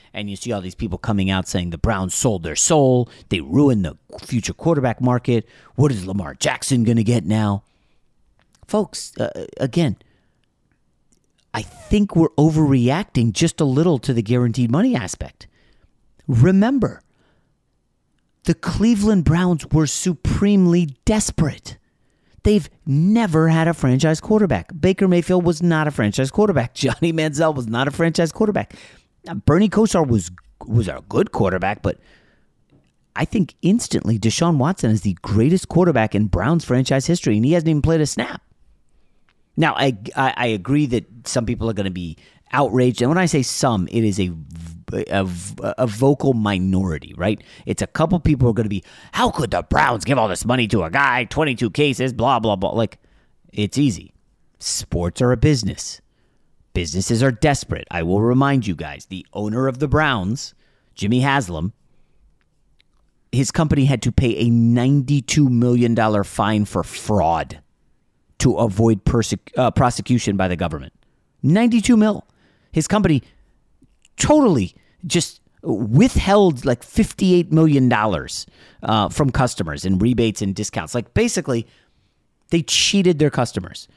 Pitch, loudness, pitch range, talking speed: 125 Hz, -19 LUFS, 105-155 Hz, 155 wpm